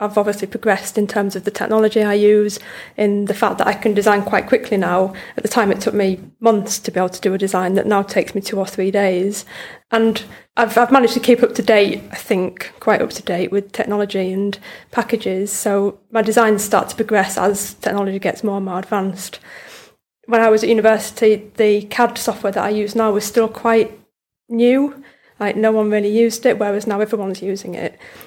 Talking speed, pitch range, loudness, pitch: 215 wpm, 200-225 Hz, -17 LUFS, 210 Hz